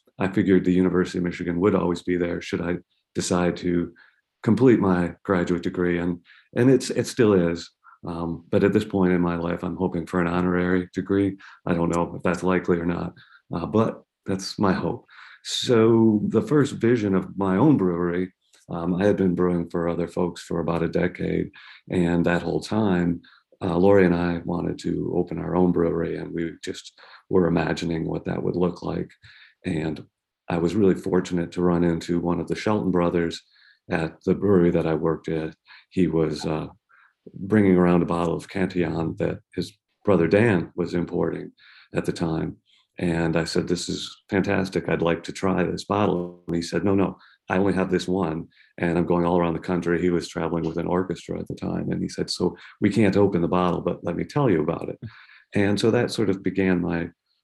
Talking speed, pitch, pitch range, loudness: 205 wpm, 90 Hz, 85-95 Hz, -24 LUFS